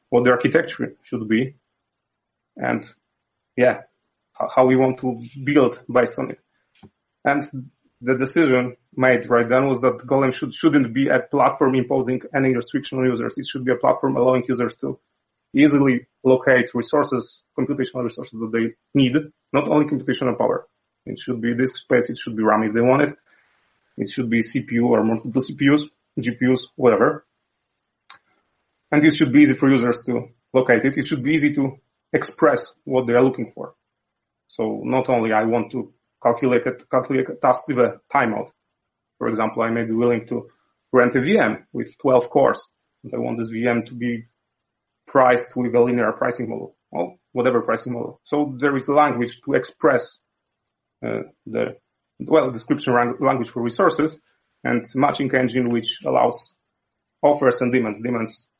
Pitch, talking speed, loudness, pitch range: 125 Hz, 170 wpm, -20 LUFS, 120-135 Hz